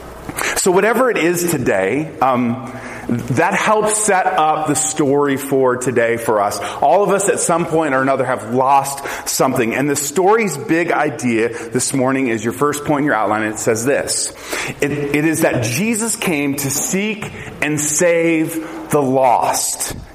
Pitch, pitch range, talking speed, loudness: 145 Hz, 130-165 Hz, 170 wpm, -16 LUFS